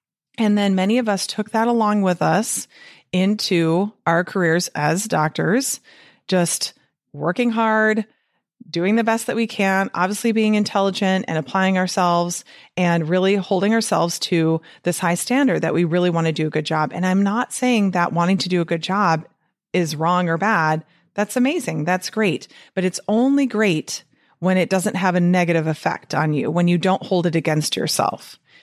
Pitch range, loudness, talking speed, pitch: 170-210 Hz, -20 LUFS, 180 wpm, 185 Hz